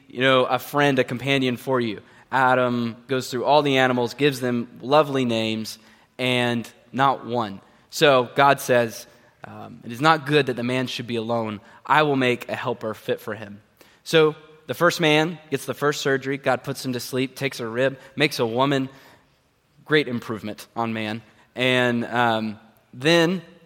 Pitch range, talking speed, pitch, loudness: 115-140 Hz, 175 wpm, 125 Hz, -22 LUFS